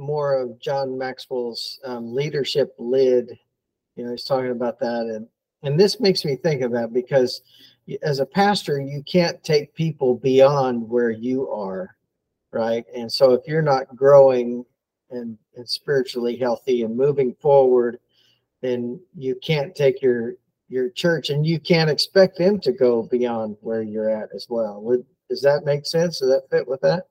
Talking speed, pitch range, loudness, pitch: 170 wpm, 120-160 Hz, -21 LUFS, 130 Hz